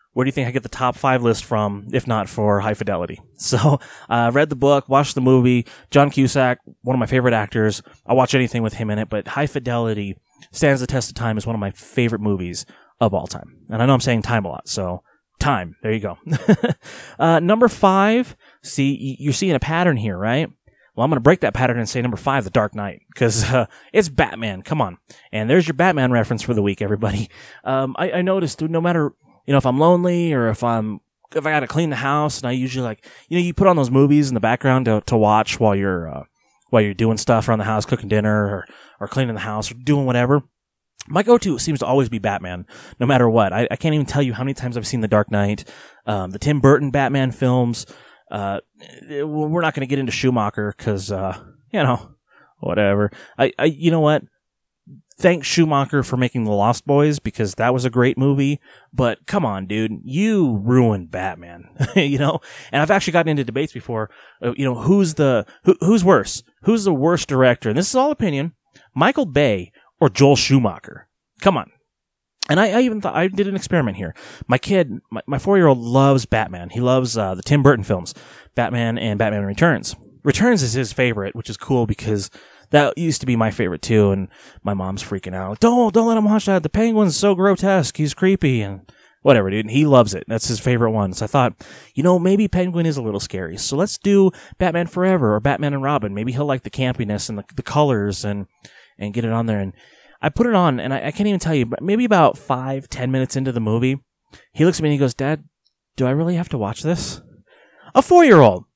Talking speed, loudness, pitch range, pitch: 230 wpm, -19 LUFS, 110-150 Hz, 130 Hz